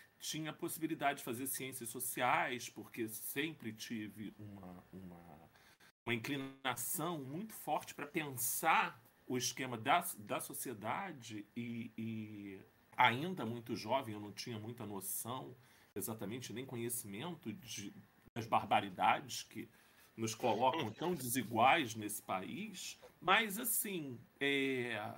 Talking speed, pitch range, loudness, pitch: 115 wpm, 110-140 Hz, -39 LUFS, 120 Hz